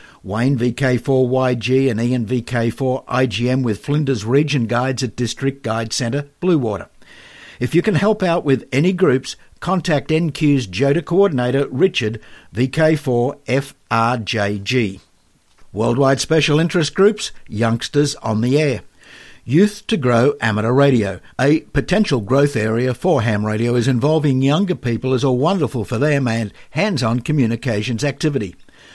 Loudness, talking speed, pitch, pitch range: -18 LUFS, 125 wpm, 130 Hz, 115-145 Hz